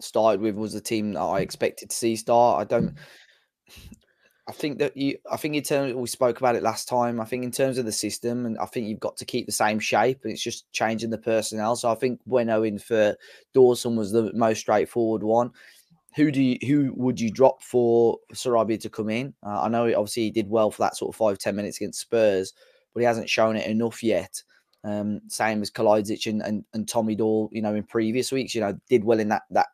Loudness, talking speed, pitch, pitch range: -24 LUFS, 240 wpm, 115 Hz, 110-125 Hz